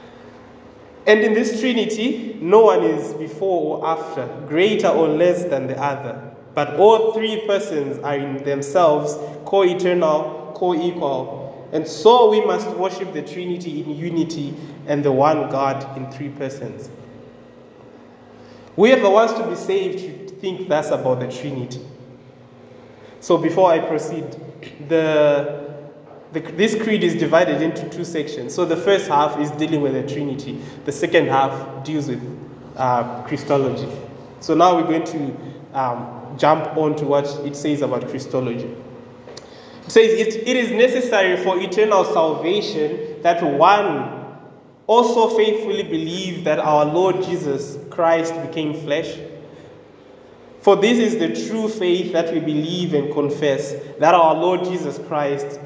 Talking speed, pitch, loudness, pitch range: 145 wpm, 155 Hz, -19 LUFS, 145-185 Hz